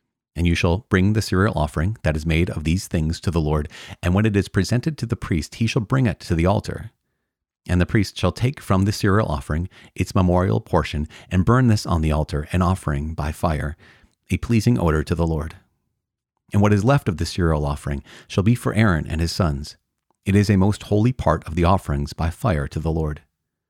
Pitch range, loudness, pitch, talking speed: 80-105 Hz, -21 LUFS, 90 Hz, 225 wpm